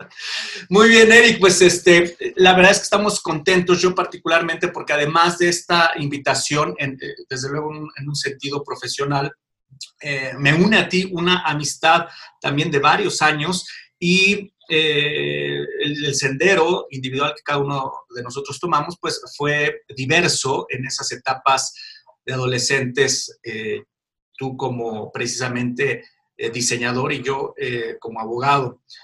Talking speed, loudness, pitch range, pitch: 135 wpm, -18 LUFS, 135-180 Hz, 150 Hz